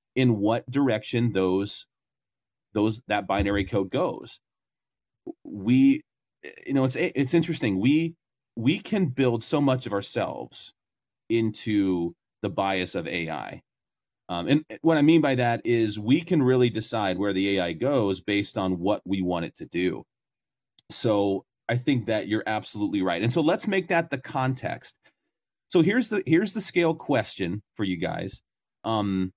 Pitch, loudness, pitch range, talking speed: 120 Hz, -24 LUFS, 100-155 Hz, 155 wpm